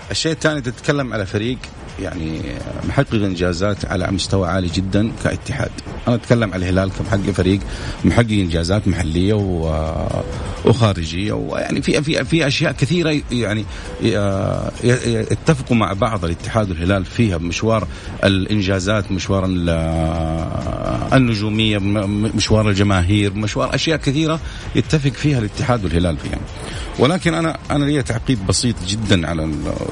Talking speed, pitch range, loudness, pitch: 115 wpm, 95-120 Hz, -18 LUFS, 105 Hz